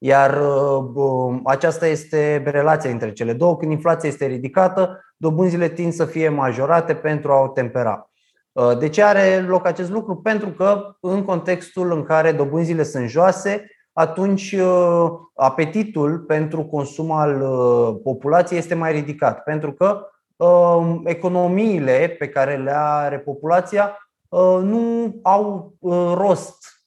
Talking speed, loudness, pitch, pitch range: 125 wpm, -19 LUFS, 165 Hz, 145-185 Hz